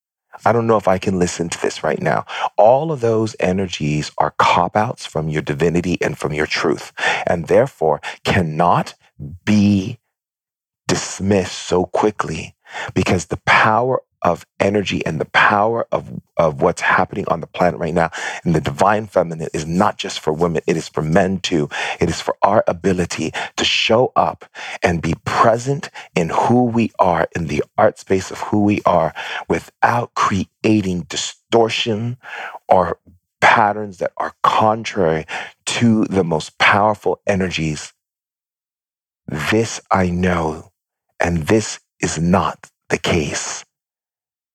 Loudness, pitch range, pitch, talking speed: -18 LUFS, 85-110 Hz, 95 Hz, 145 wpm